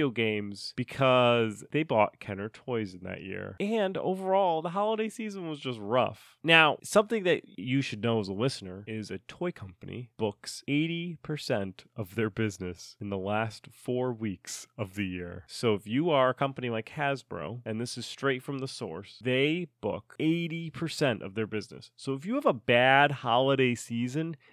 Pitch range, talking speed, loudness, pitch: 110-150 Hz, 175 wpm, -29 LUFS, 125 Hz